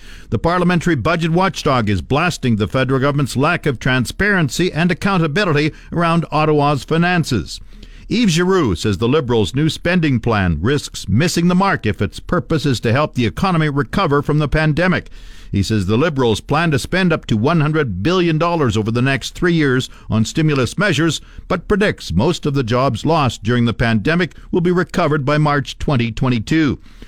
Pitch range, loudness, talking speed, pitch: 120-170 Hz, -17 LUFS, 170 wpm, 150 Hz